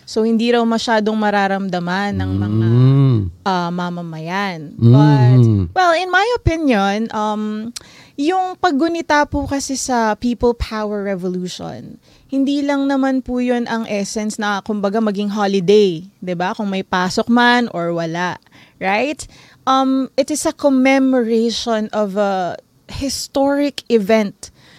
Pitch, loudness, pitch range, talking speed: 215 Hz, -17 LUFS, 185-265 Hz, 125 wpm